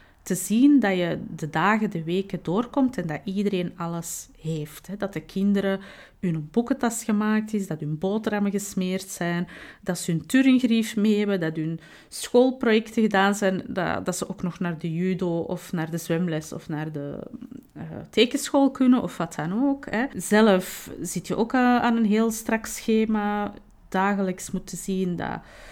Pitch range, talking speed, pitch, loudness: 175-225 Hz, 165 wpm, 195 Hz, -25 LUFS